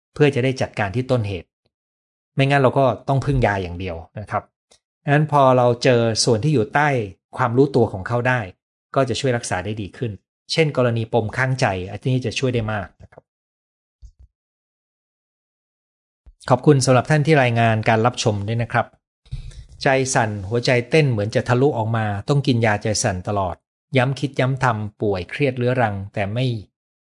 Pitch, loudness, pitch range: 120 Hz, -20 LUFS, 100-130 Hz